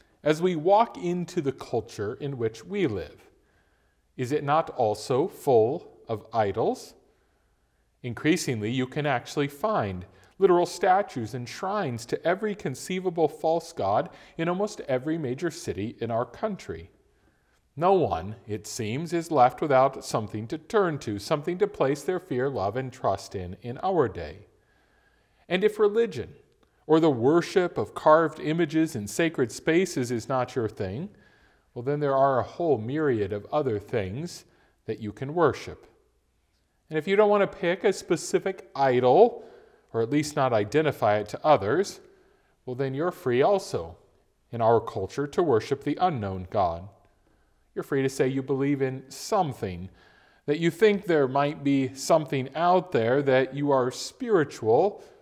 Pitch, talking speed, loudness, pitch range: 140 Hz, 155 wpm, -26 LUFS, 120-170 Hz